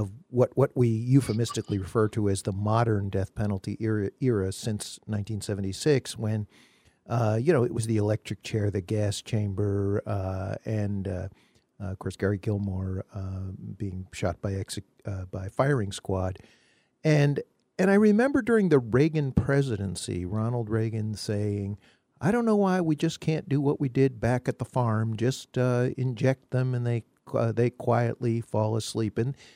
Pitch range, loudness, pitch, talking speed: 100-125 Hz, -27 LUFS, 110 Hz, 170 wpm